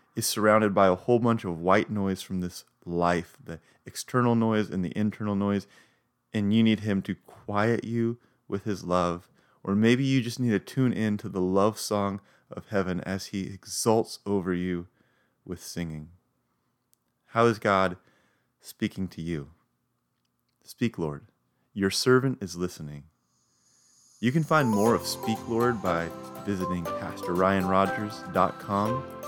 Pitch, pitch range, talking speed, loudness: 100 Hz, 90-110 Hz, 150 wpm, -27 LUFS